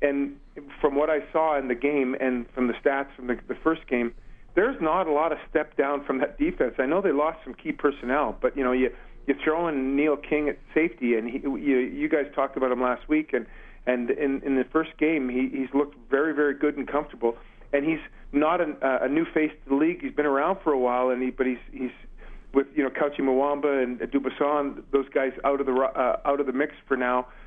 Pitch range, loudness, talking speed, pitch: 130-150 Hz, -26 LUFS, 240 wpm, 140 Hz